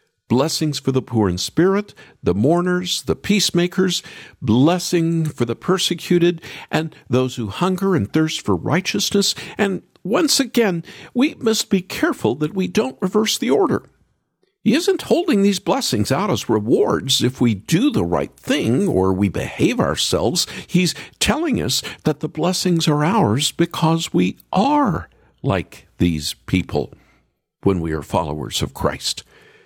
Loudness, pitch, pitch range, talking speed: -19 LUFS, 170 Hz, 130-195 Hz, 150 wpm